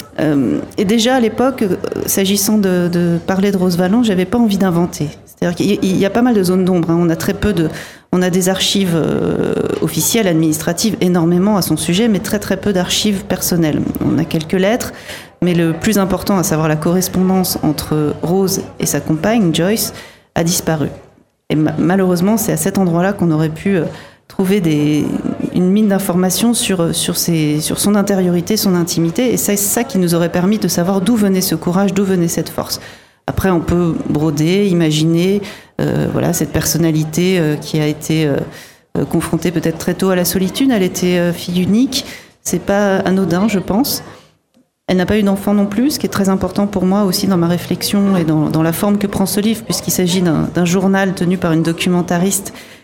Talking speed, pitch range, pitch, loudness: 195 wpm, 170-200 Hz, 185 Hz, -15 LUFS